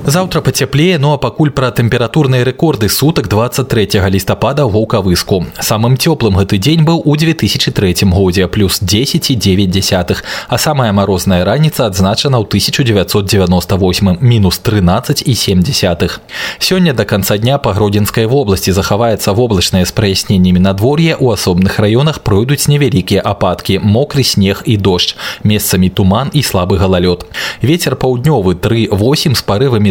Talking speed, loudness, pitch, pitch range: 135 wpm, -11 LUFS, 110 Hz, 95-135 Hz